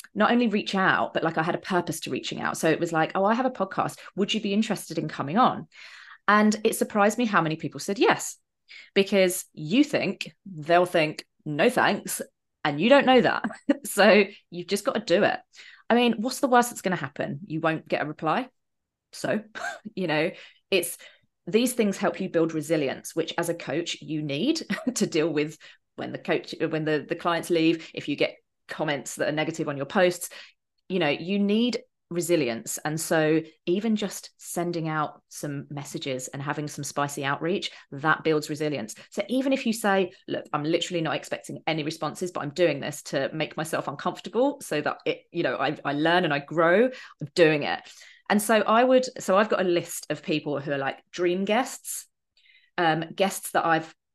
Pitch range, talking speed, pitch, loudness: 155-210 Hz, 205 wpm, 175 Hz, -26 LUFS